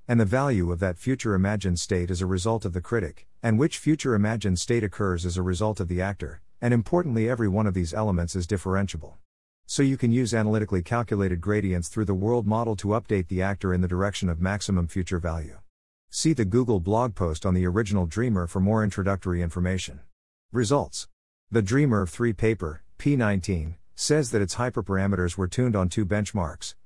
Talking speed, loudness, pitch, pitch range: 190 wpm, -26 LUFS, 100 Hz, 90-115 Hz